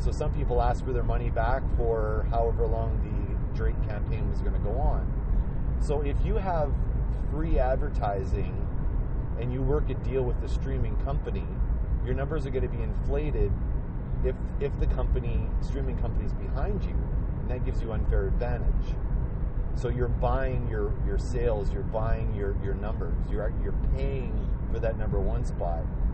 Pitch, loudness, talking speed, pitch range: 105 Hz, -30 LUFS, 170 wpm, 80-115 Hz